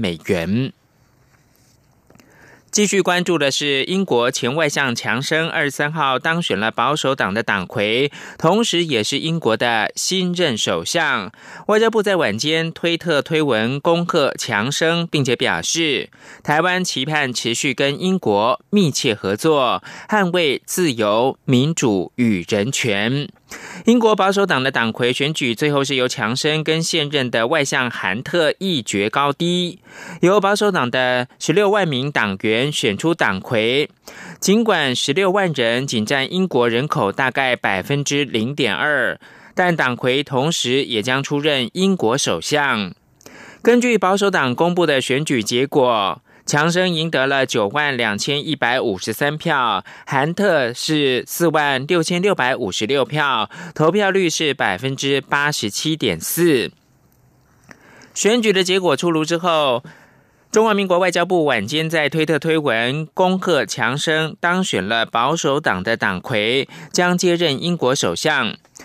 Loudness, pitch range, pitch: -18 LUFS, 130-180 Hz, 155 Hz